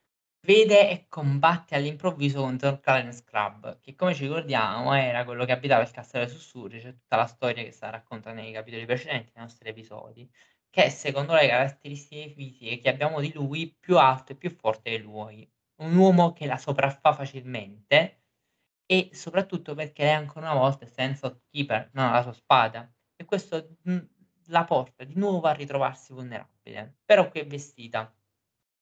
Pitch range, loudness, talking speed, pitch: 120-155 Hz, -25 LUFS, 170 wpm, 135 Hz